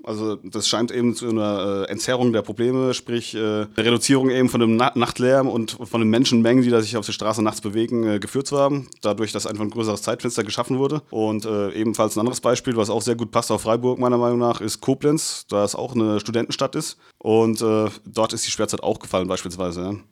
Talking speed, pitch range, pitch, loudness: 210 wpm, 110-120 Hz, 115 Hz, -21 LUFS